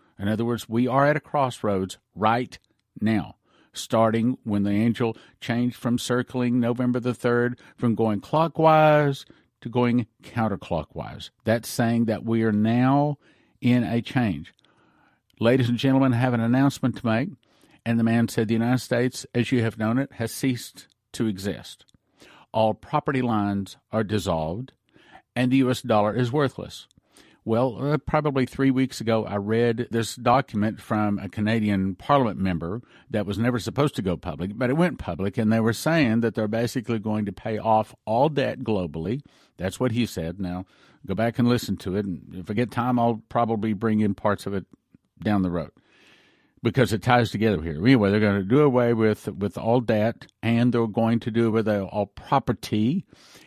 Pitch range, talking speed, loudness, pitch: 105-125 Hz, 180 wpm, -24 LUFS, 115 Hz